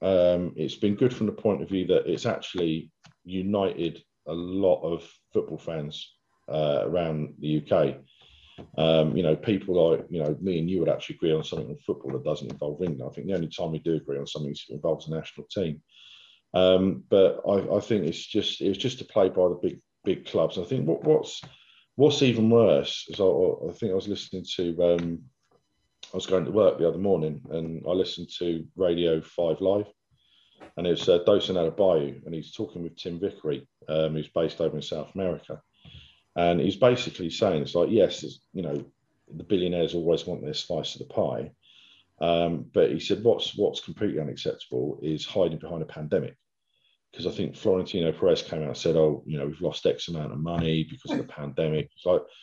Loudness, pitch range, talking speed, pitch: -27 LUFS, 80-95 Hz, 210 wpm, 85 Hz